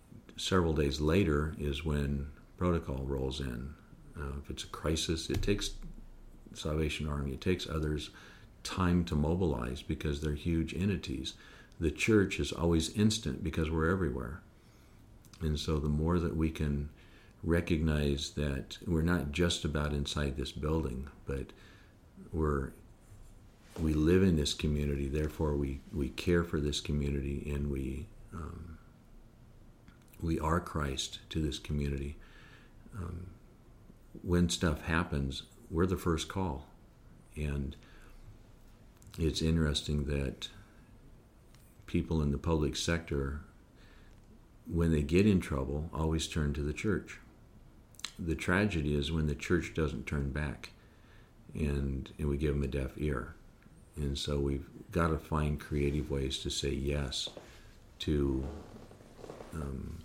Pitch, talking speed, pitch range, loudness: 80 Hz, 130 wpm, 70-90 Hz, -34 LUFS